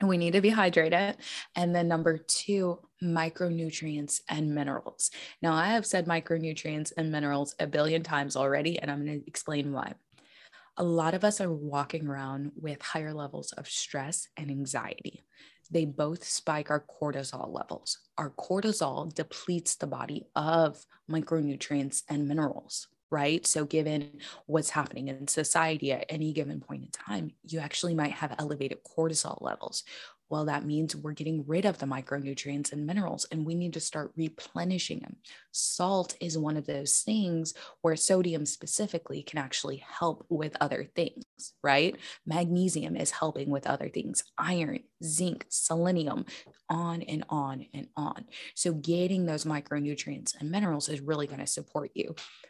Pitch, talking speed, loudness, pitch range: 160 Hz, 160 wpm, -31 LUFS, 145-170 Hz